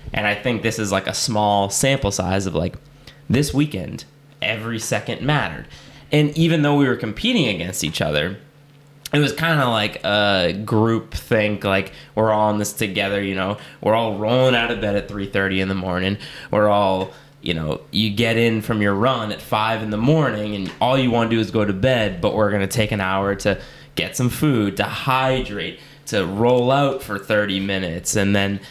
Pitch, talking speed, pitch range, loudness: 105 Hz, 205 wpm, 100-130 Hz, -20 LUFS